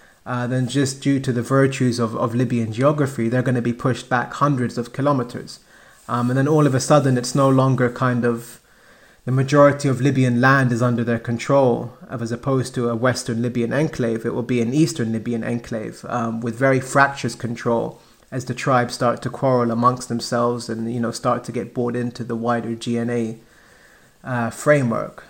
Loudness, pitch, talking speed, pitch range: -20 LUFS, 125 Hz, 195 wpm, 120-130 Hz